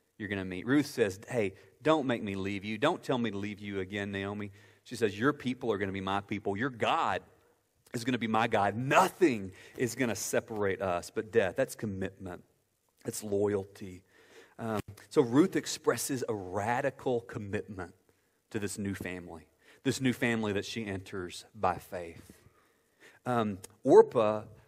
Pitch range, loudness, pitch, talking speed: 95-115 Hz, -32 LUFS, 105 Hz, 175 wpm